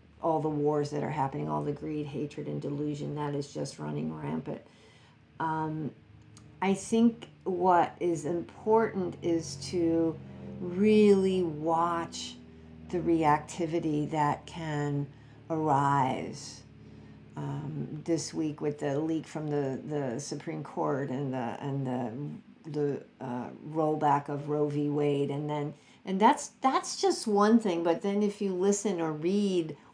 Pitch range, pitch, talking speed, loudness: 140-175 Hz, 150 Hz, 140 wpm, -30 LUFS